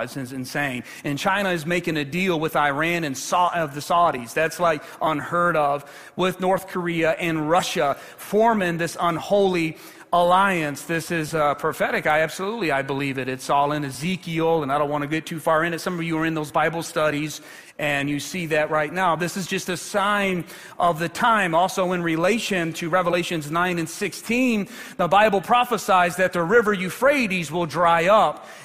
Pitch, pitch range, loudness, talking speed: 170 Hz, 155-185 Hz, -22 LUFS, 195 wpm